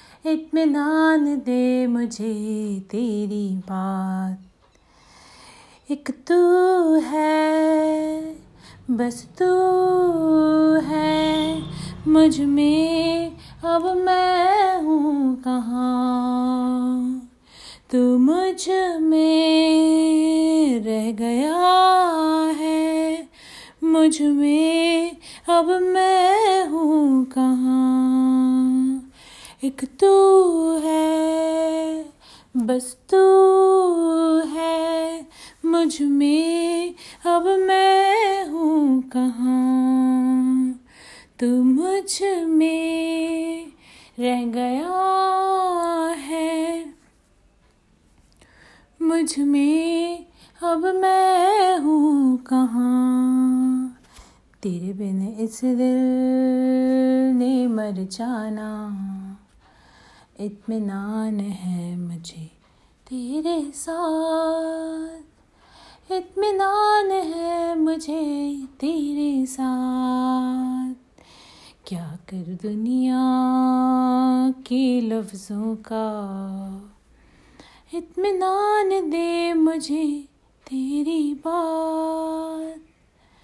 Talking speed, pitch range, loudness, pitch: 60 wpm, 255-330 Hz, -20 LUFS, 305 Hz